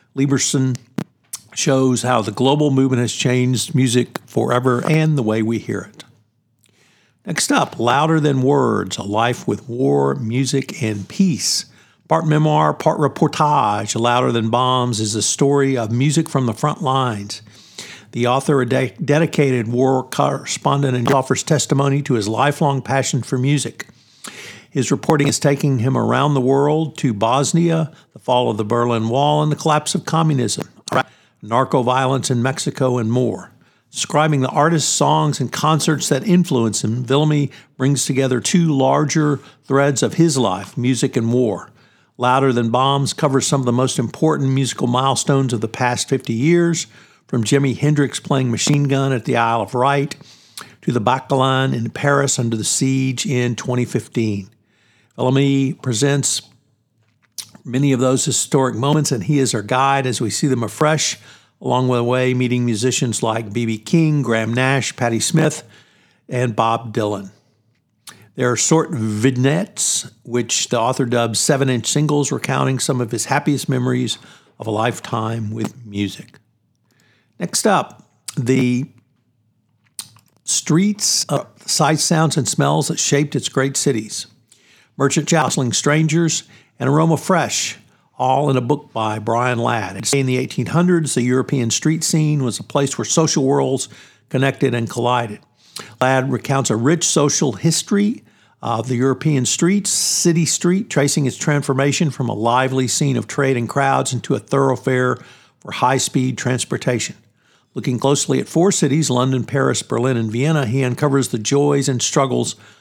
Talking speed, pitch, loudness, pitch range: 155 wpm, 130 Hz, -18 LUFS, 120-145 Hz